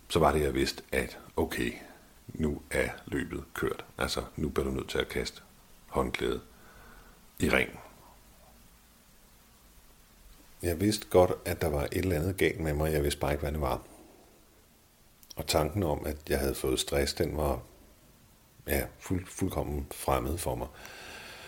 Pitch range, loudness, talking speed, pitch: 70-85 Hz, -31 LUFS, 160 wpm, 75 Hz